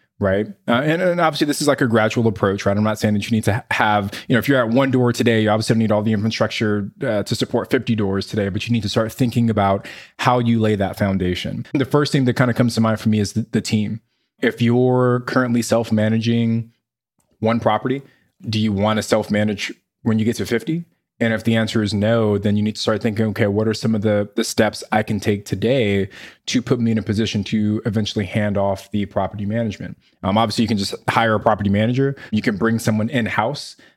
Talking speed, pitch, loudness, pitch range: 245 wpm, 110 Hz, -19 LUFS, 105-120 Hz